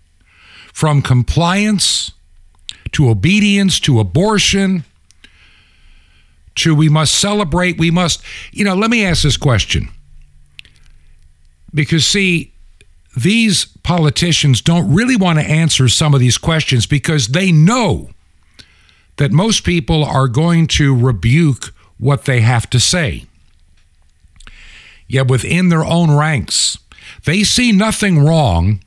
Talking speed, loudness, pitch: 115 wpm, -13 LUFS, 135 Hz